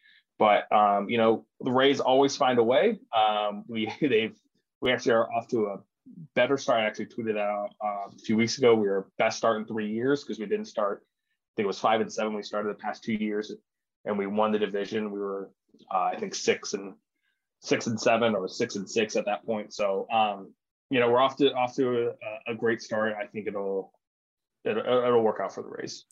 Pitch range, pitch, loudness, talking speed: 105-125 Hz, 110 Hz, -27 LUFS, 225 wpm